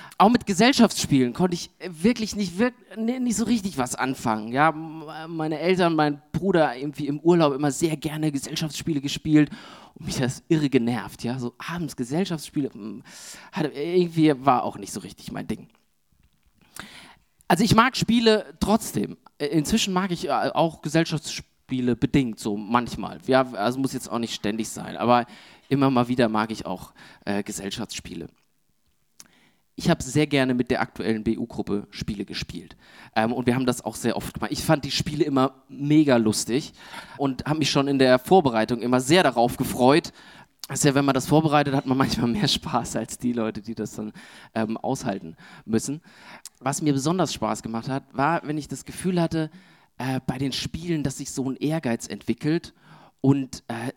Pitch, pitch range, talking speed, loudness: 140 Hz, 120-165 Hz, 170 wpm, -24 LUFS